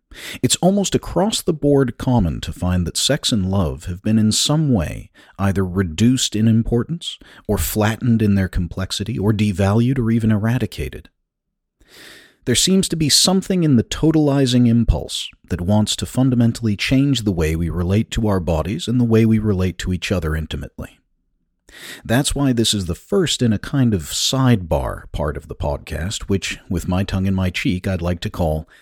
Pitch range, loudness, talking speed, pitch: 90-125 Hz, -18 LUFS, 180 wpm, 105 Hz